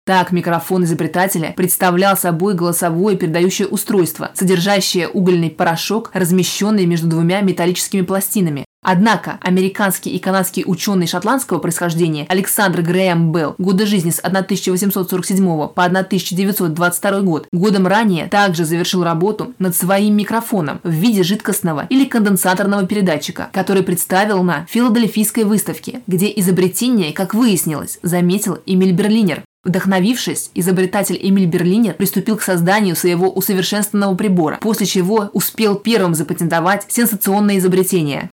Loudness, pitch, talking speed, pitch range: -15 LUFS, 190 Hz, 120 wpm, 175-200 Hz